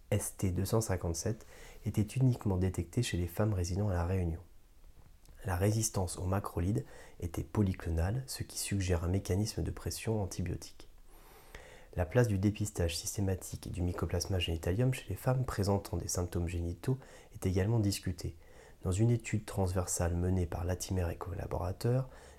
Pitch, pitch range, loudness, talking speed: 95 Hz, 85-105 Hz, -35 LUFS, 140 wpm